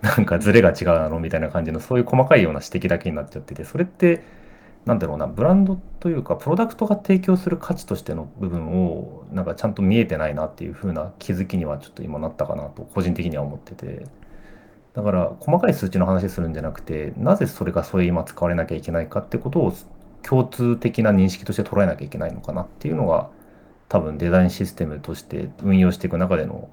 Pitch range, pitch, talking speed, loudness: 85-120 Hz, 95 Hz, 475 characters per minute, -22 LUFS